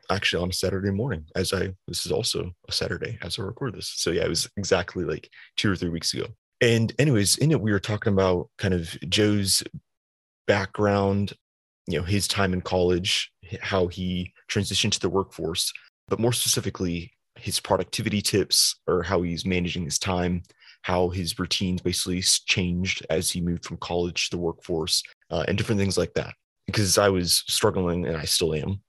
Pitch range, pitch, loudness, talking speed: 90-100 Hz, 95 Hz, -25 LUFS, 185 wpm